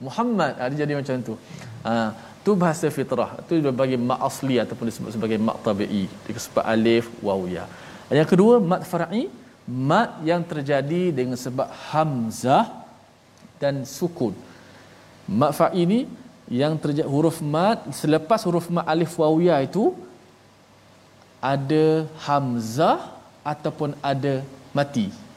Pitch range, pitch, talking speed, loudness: 125-170 Hz, 145 Hz, 130 wpm, -23 LUFS